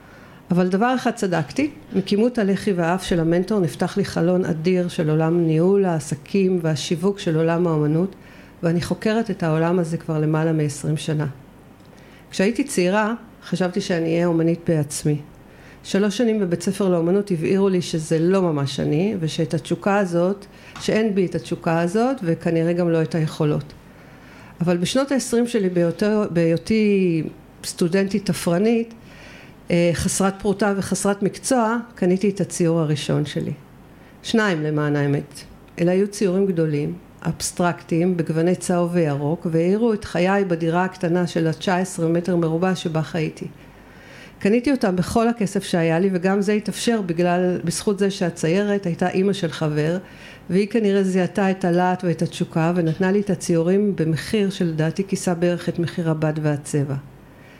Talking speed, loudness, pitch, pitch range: 140 wpm, -21 LUFS, 180 Hz, 165-195 Hz